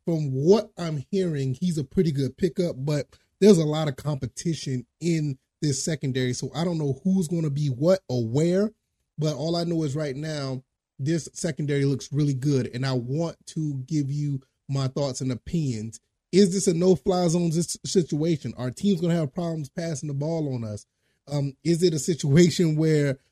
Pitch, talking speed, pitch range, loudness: 155 Hz, 195 wpm, 135-170 Hz, -25 LUFS